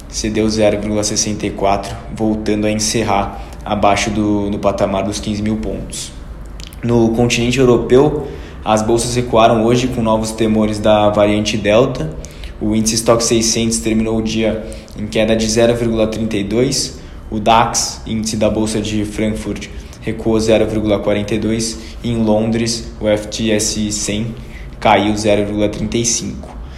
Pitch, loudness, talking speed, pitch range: 110 Hz, -15 LUFS, 120 wpm, 105-115 Hz